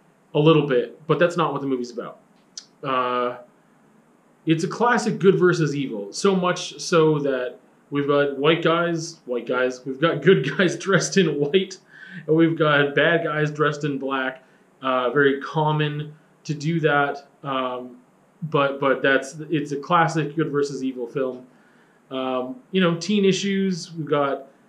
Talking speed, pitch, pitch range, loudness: 160 wpm, 150 Hz, 135-175 Hz, -22 LUFS